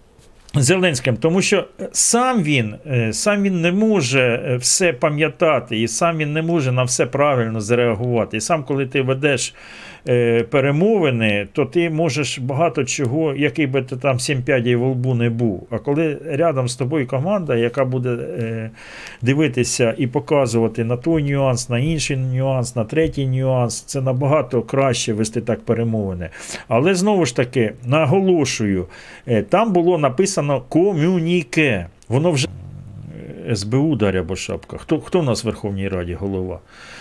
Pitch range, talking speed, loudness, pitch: 120-155 Hz, 145 wpm, -18 LUFS, 135 Hz